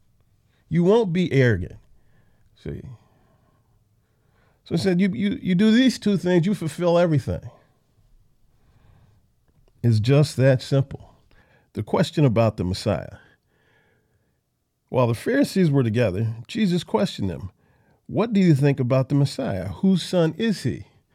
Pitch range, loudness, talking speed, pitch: 115-180 Hz, -21 LUFS, 130 wpm, 135 Hz